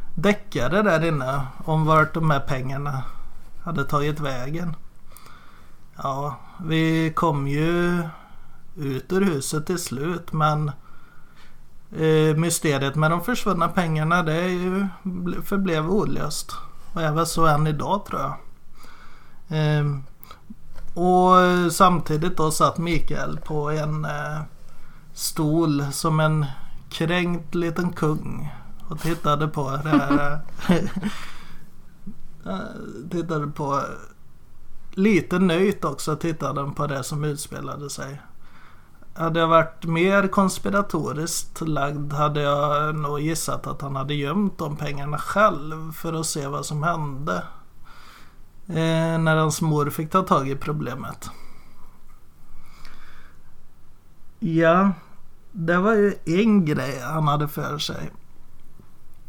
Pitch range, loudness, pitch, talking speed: 145-175 Hz, -23 LUFS, 155 Hz, 115 wpm